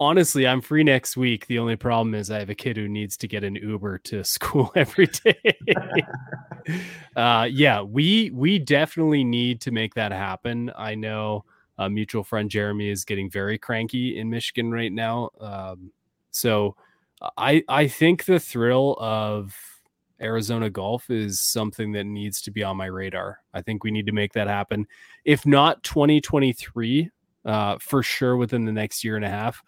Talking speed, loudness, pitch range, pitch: 175 wpm, -23 LUFS, 105-130 Hz, 115 Hz